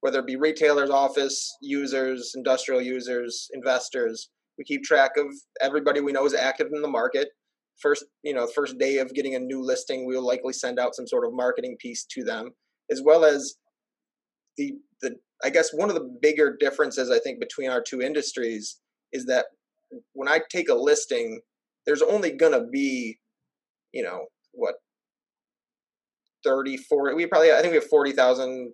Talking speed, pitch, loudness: 175 wpm, 150 Hz, -24 LUFS